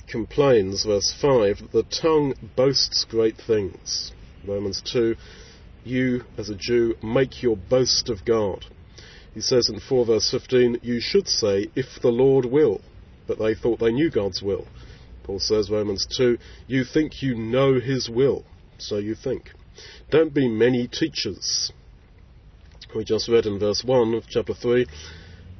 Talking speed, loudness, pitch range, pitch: 155 wpm, -22 LUFS, 100-125 Hz, 115 Hz